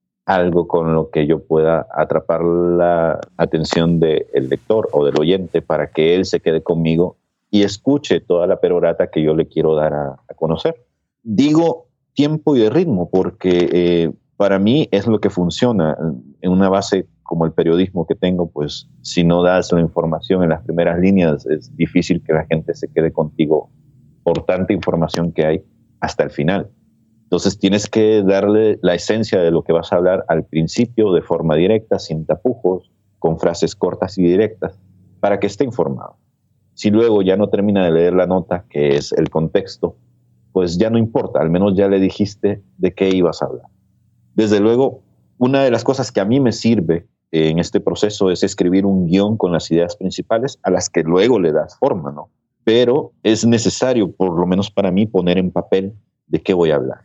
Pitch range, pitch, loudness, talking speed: 85-105 Hz, 95 Hz, -16 LUFS, 190 wpm